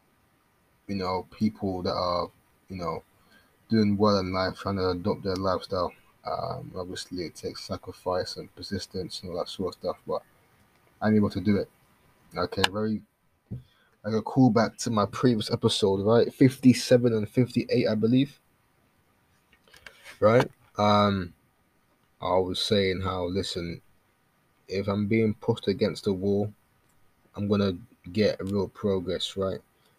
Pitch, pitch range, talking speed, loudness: 100 Hz, 95-110 Hz, 140 wpm, -27 LUFS